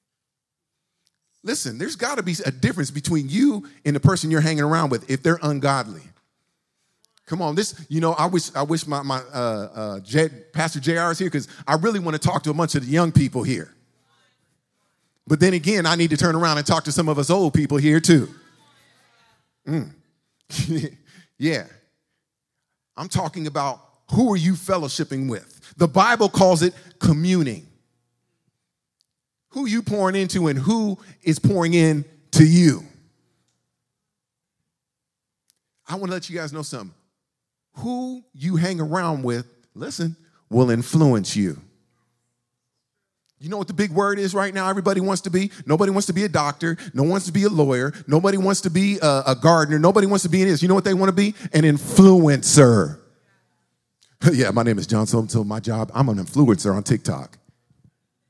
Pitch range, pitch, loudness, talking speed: 140-185 Hz, 160 Hz, -20 LUFS, 180 wpm